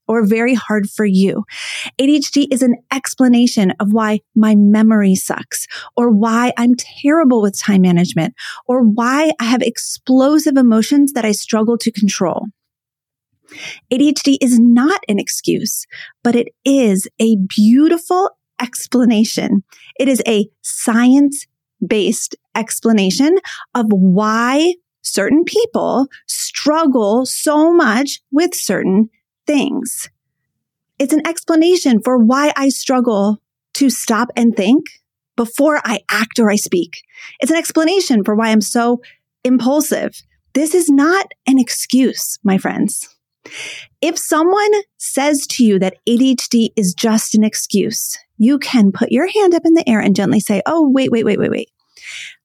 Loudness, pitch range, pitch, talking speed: -14 LUFS, 220-285 Hz, 245 Hz, 135 wpm